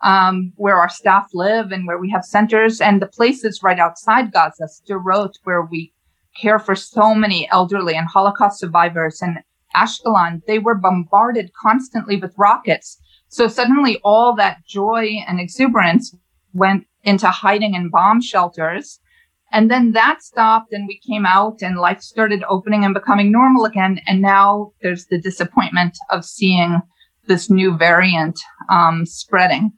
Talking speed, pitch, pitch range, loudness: 155 wpm, 195 Hz, 180-215 Hz, -15 LUFS